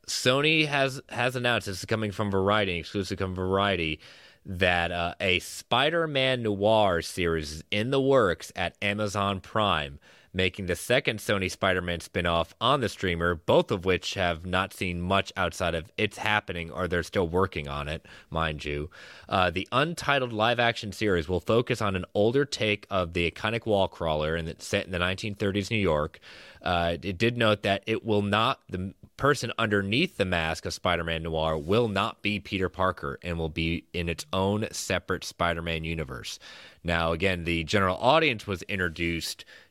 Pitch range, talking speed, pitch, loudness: 85-105 Hz, 180 wpm, 95 Hz, -27 LUFS